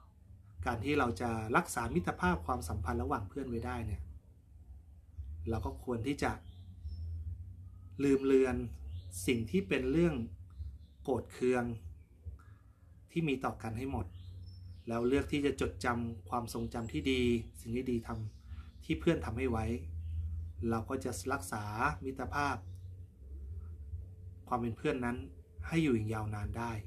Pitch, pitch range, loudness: 100 Hz, 85-125 Hz, -36 LUFS